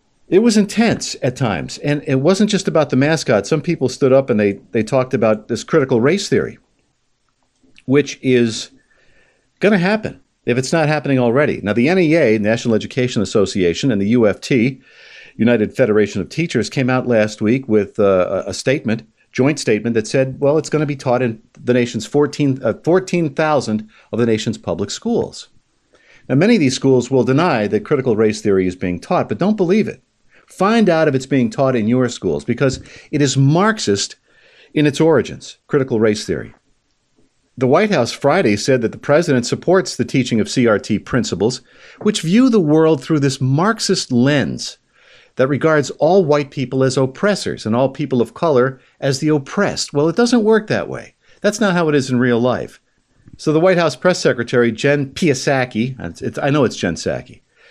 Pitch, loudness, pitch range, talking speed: 135 Hz, -16 LUFS, 120-160 Hz, 185 wpm